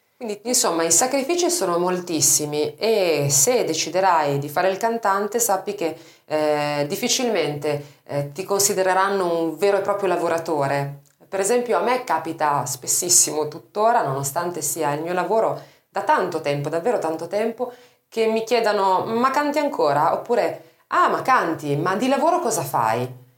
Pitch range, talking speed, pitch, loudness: 150-220 Hz, 150 wpm, 180 Hz, -21 LUFS